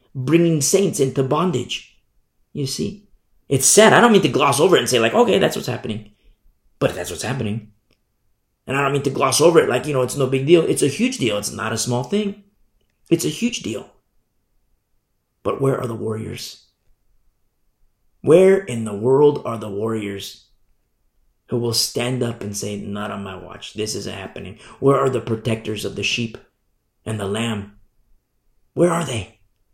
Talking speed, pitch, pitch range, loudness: 185 wpm, 115 Hz, 105-135 Hz, -19 LUFS